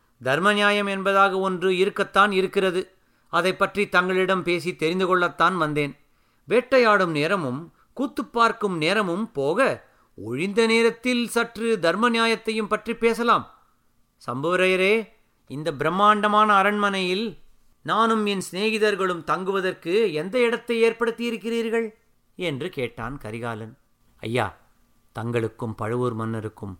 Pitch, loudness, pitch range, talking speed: 190 Hz, -22 LUFS, 150-220 Hz, 100 wpm